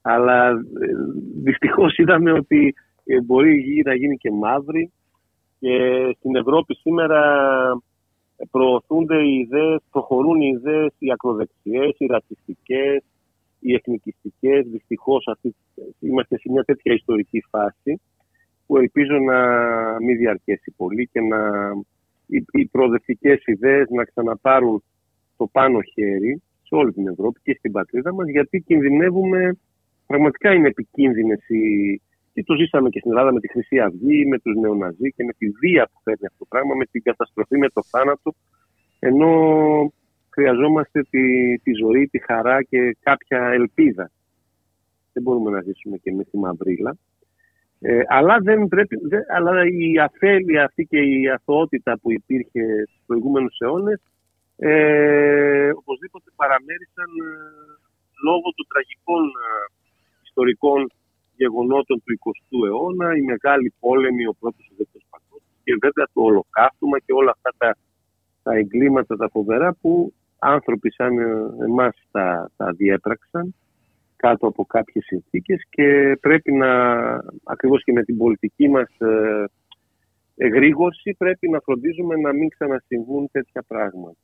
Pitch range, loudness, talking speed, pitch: 115-155 Hz, -19 LUFS, 130 wpm, 130 Hz